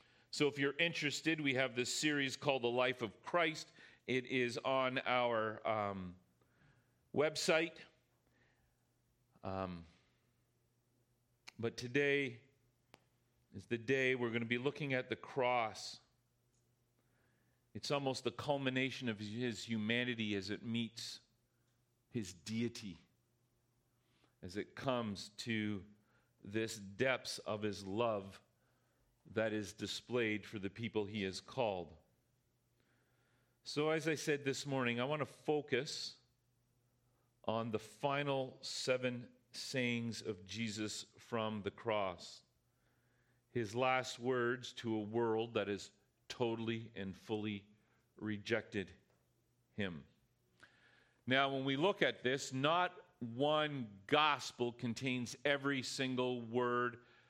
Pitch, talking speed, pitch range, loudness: 120 Hz, 115 wpm, 110-130 Hz, -39 LUFS